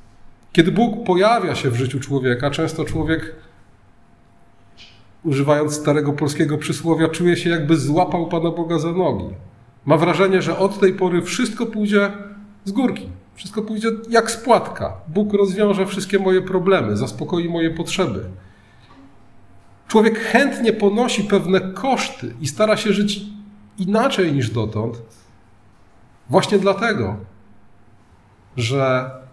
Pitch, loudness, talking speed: 165 Hz, -19 LUFS, 120 wpm